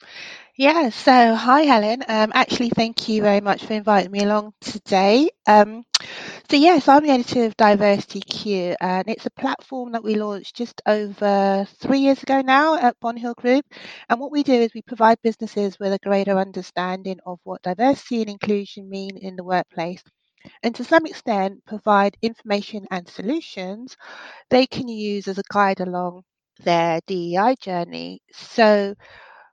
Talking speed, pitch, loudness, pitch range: 165 wpm, 215 Hz, -19 LUFS, 195-245 Hz